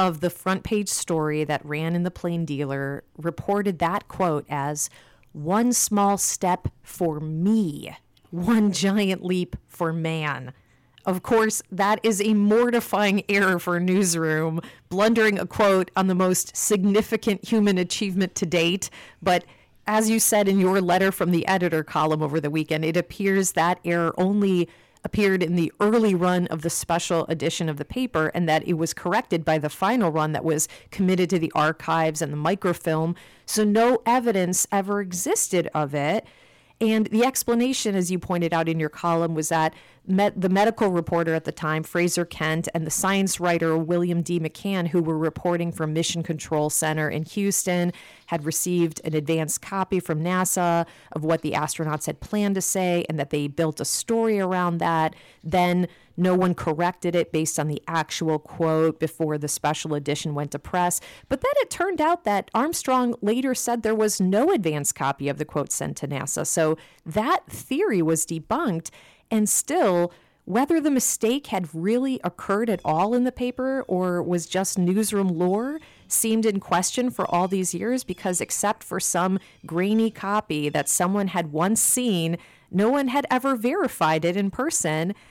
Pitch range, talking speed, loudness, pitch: 160-205 Hz, 175 wpm, -23 LUFS, 180 Hz